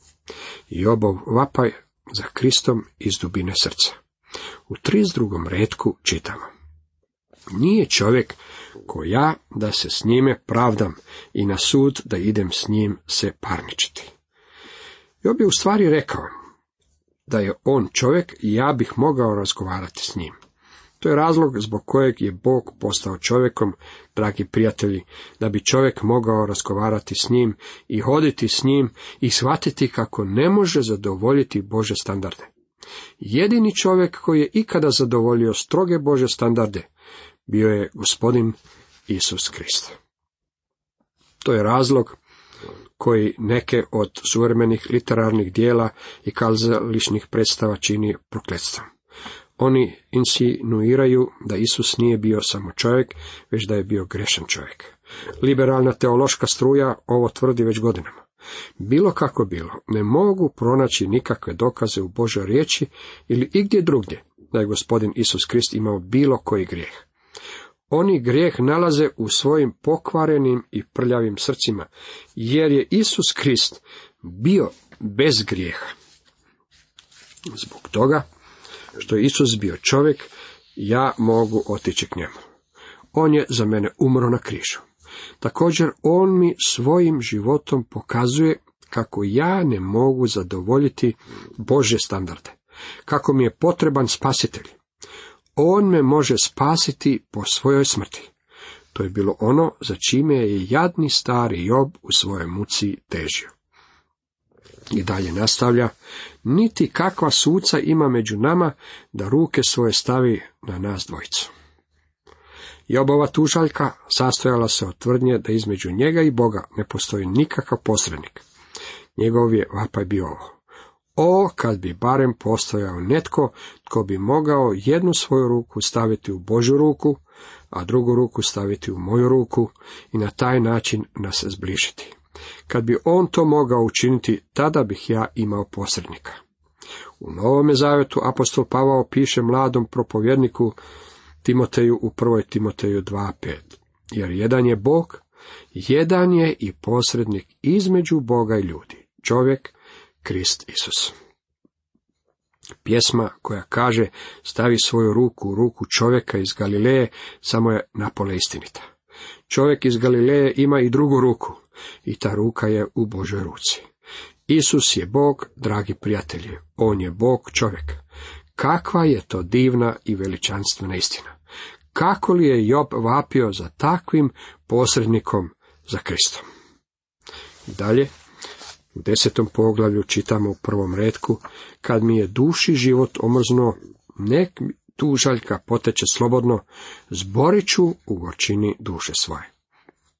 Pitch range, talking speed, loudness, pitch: 105-135 Hz, 125 wpm, -20 LUFS, 115 Hz